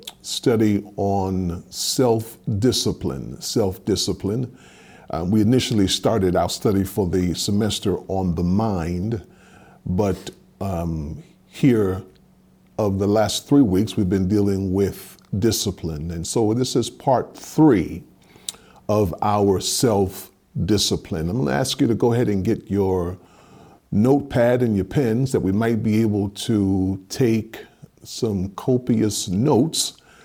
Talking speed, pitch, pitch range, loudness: 125 wpm, 100 Hz, 95-115 Hz, -21 LUFS